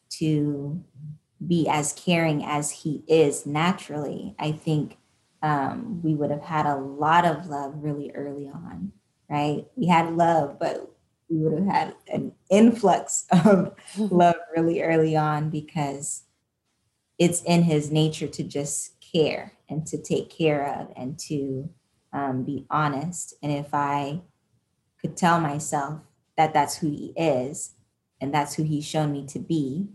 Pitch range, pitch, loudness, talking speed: 145-165 Hz, 150 Hz, -25 LUFS, 150 wpm